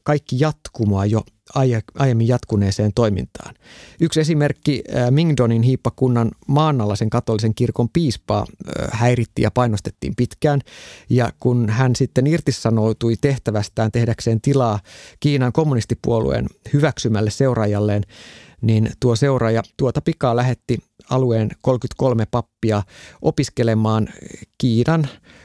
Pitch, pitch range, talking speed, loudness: 120 Hz, 110-135 Hz, 100 wpm, -19 LUFS